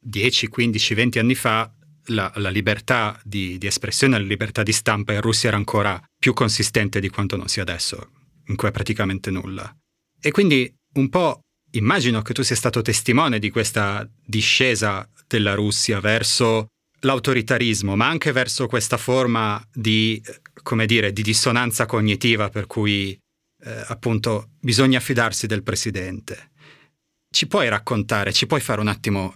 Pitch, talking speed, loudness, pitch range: 110 Hz, 155 wpm, -20 LUFS, 105-125 Hz